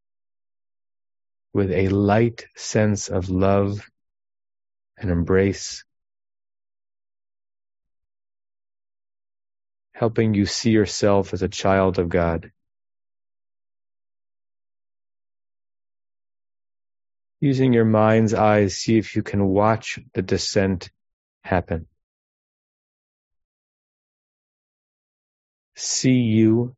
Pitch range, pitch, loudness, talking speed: 95-100 Hz, 100 Hz, -21 LUFS, 70 wpm